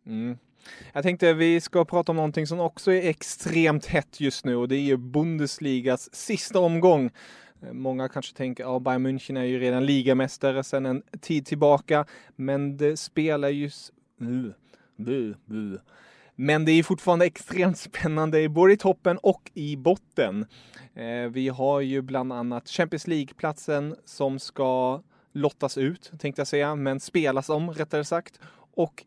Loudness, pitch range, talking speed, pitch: -25 LUFS, 130-165 Hz, 150 wpm, 145 Hz